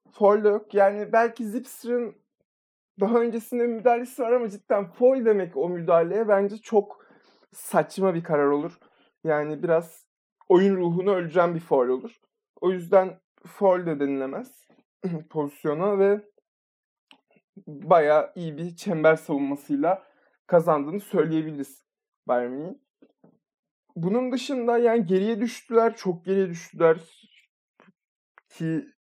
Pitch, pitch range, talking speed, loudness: 195 Hz, 165-230 Hz, 105 wpm, -24 LUFS